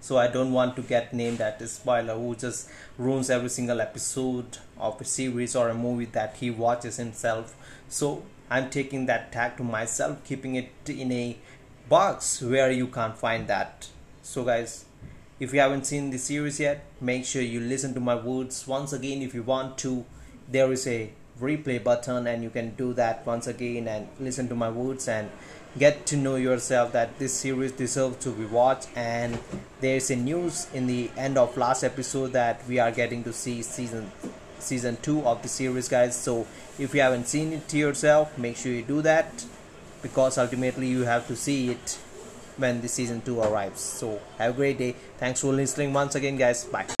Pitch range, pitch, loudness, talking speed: 120-135 Hz, 125 Hz, -27 LUFS, 200 wpm